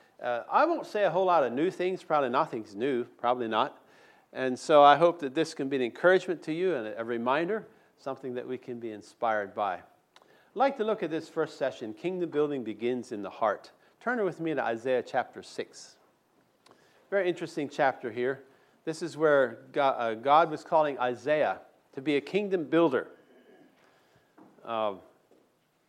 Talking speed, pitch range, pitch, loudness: 175 wpm, 130-180 Hz, 155 Hz, -29 LUFS